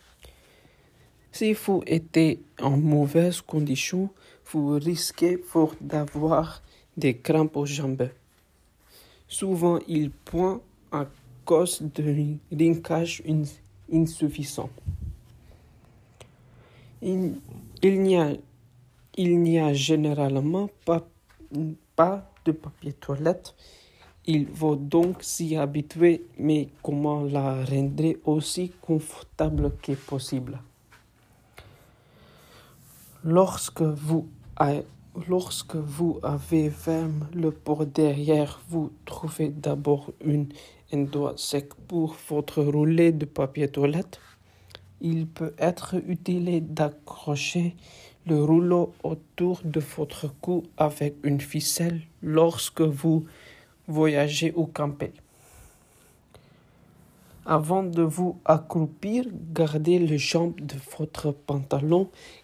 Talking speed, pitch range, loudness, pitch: 95 wpm, 145-165 Hz, -26 LUFS, 155 Hz